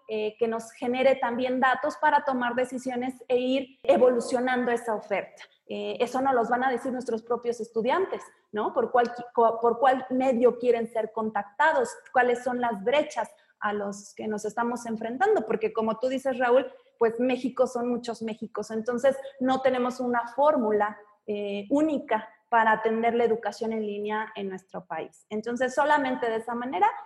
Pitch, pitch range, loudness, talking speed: 240 Hz, 220-260 Hz, -27 LUFS, 160 wpm